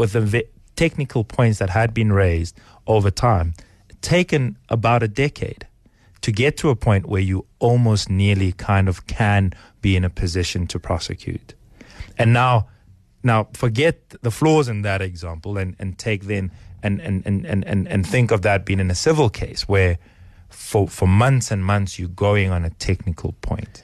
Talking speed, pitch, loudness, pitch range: 180 wpm, 100 Hz, -20 LUFS, 95-115 Hz